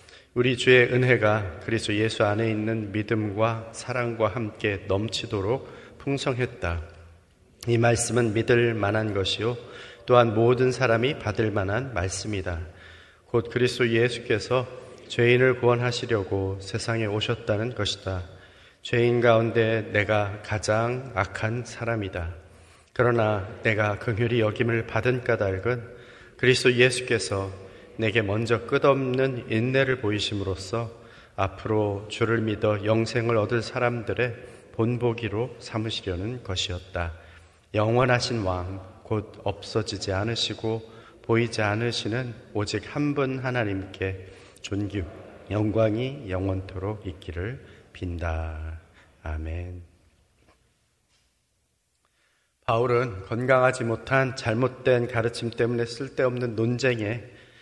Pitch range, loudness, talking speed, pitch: 100-120 Hz, -25 LUFS, 250 characters per minute, 110 Hz